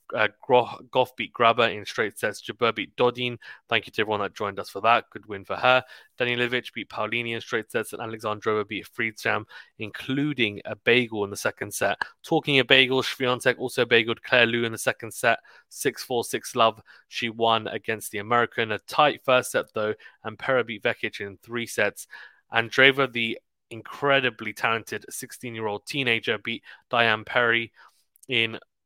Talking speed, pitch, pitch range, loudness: 180 wpm, 115 Hz, 110-125 Hz, -24 LUFS